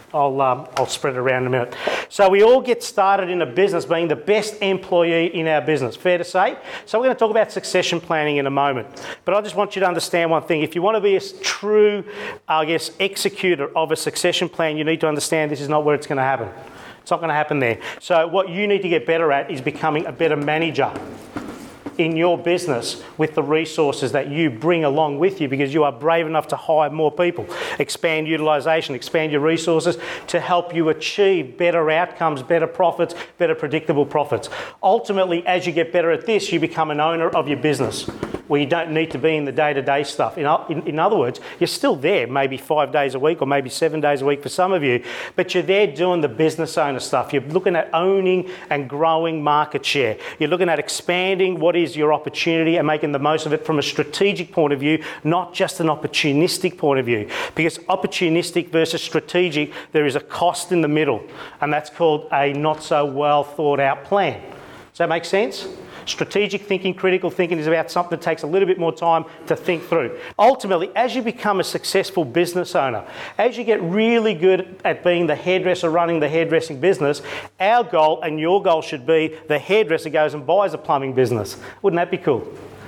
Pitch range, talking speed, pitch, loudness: 150-180 Hz, 220 wpm, 165 Hz, -20 LUFS